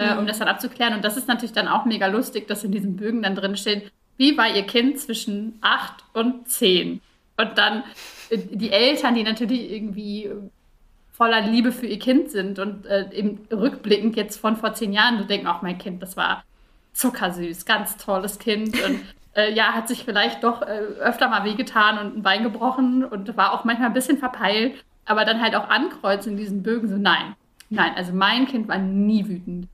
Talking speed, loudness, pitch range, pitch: 205 wpm, -22 LUFS, 205-235 Hz, 215 Hz